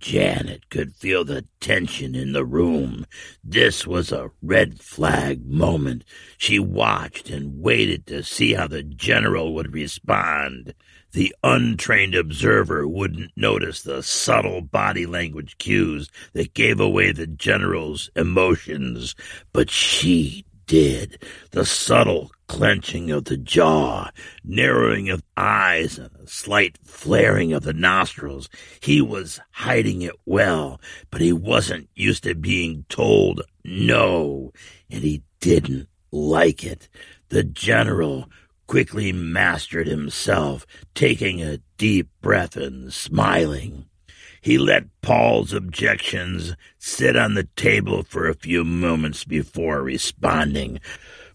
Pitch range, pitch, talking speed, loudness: 75-85 Hz, 80 Hz, 120 wpm, -20 LUFS